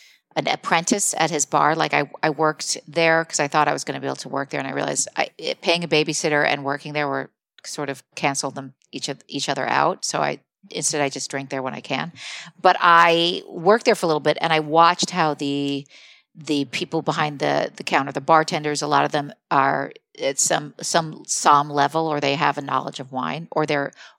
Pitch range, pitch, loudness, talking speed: 145-170 Hz, 155 Hz, -21 LUFS, 230 wpm